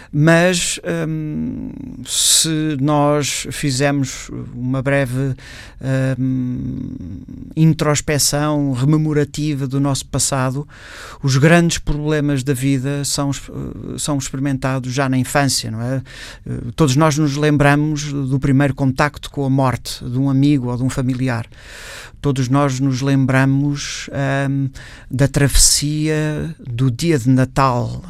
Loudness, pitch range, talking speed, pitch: -17 LUFS, 130-145 Hz, 115 wpm, 140 Hz